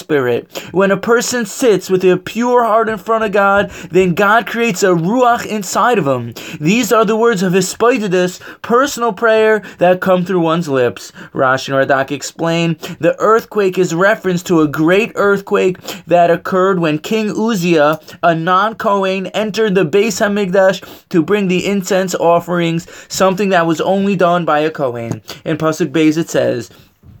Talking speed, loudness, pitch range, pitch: 170 wpm, -14 LUFS, 165-210 Hz, 185 Hz